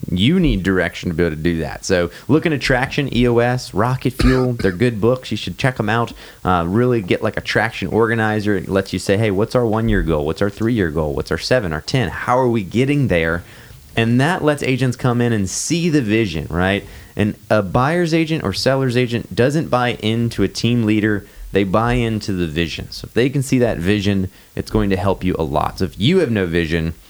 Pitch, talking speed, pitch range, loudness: 110 Hz, 235 wpm, 95-125 Hz, -18 LUFS